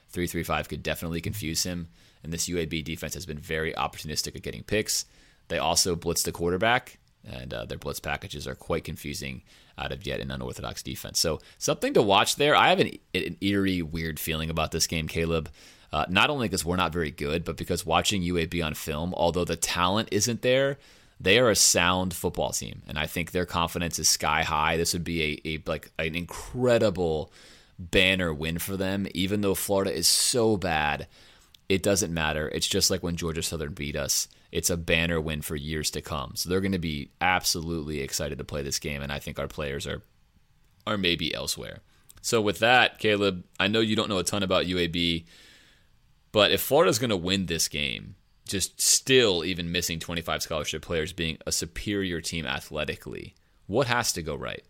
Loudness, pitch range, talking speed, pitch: -26 LUFS, 80-95 Hz, 200 wpm, 85 Hz